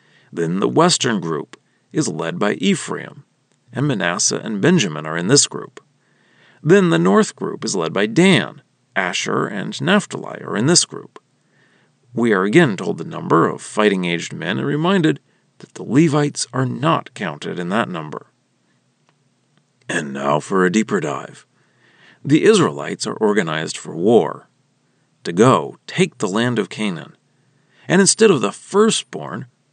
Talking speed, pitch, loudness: 155 wpm, 145 Hz, -18 LUFS